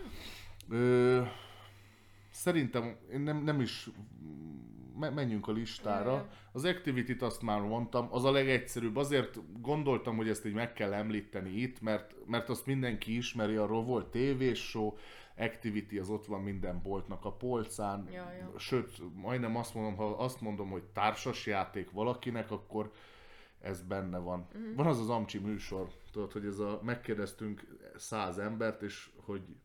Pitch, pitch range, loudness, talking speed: 110 Hz, 100-125 Hz, -36 LUFS, 145 wpm